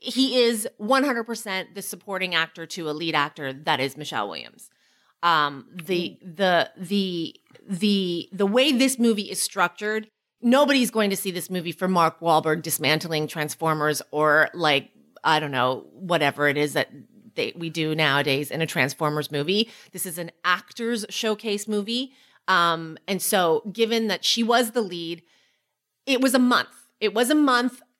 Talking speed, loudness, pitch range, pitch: 165 wpm, -23 LUFS, 160-230 Hz, 185 Hz